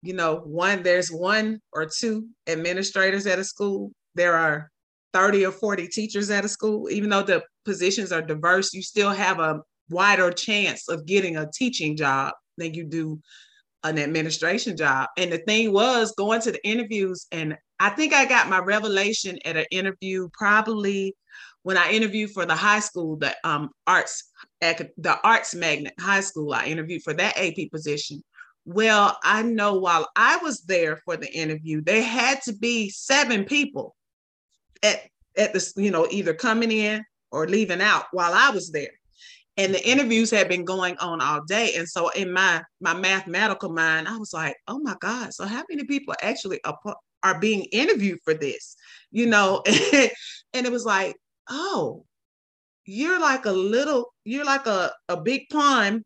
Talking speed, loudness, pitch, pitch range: 175 wpm, -23 LUFS, 195 Hz, 170-220 Hz